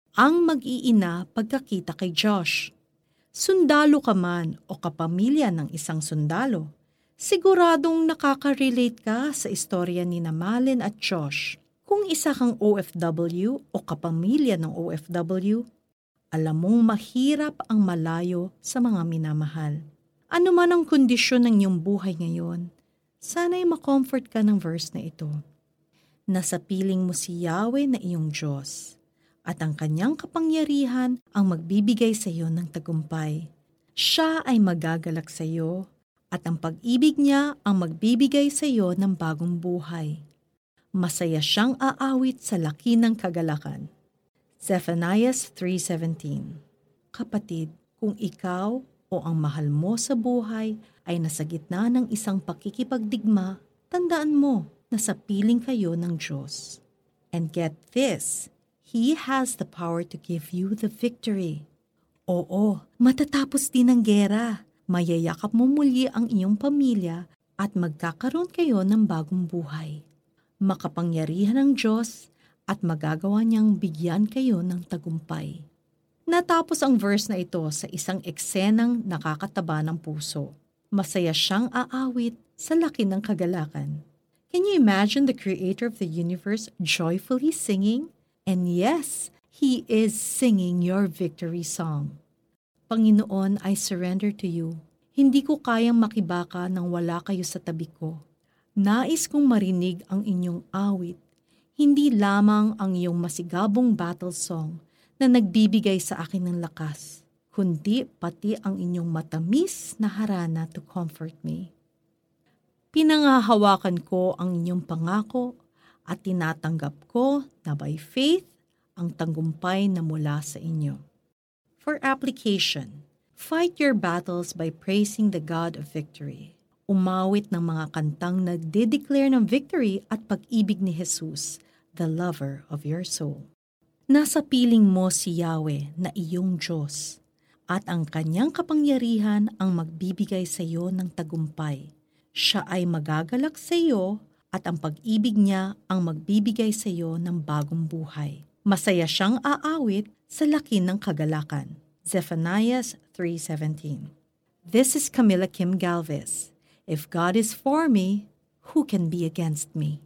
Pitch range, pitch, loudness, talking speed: 165-230 Hz, 185 Hz, -25 LUFS, 130 wpm